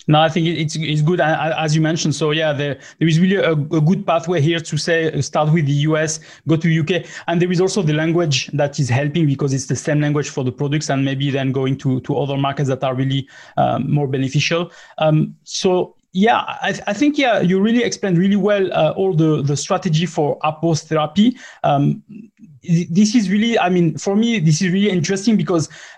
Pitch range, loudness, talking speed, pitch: 145-185 Hz, -18 LUFS, 220 wpm, 160 Hz